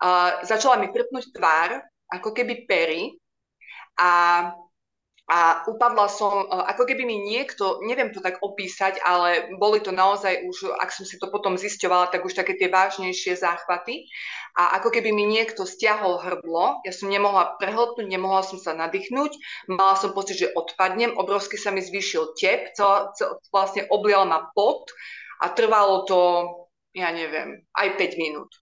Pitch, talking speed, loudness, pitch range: 195 Hz, 160 wpm, -23 LUFS, 180-210 Hz